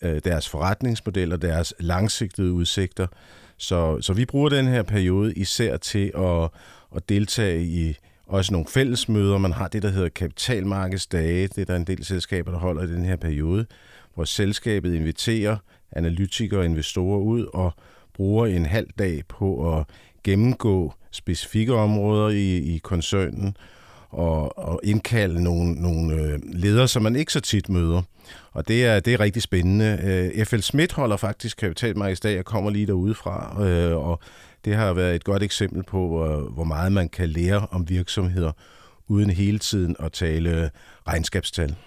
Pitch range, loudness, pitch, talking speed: 85-105 Hz, -23 LUFS, 95 Hz, 155 wpm